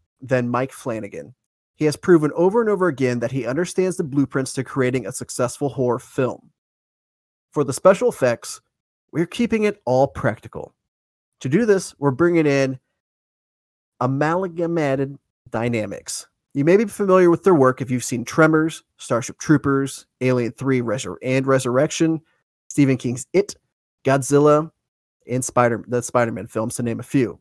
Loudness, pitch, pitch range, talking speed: -20 LUFS, 135 Hz, 125-160 Hz, 150 wpm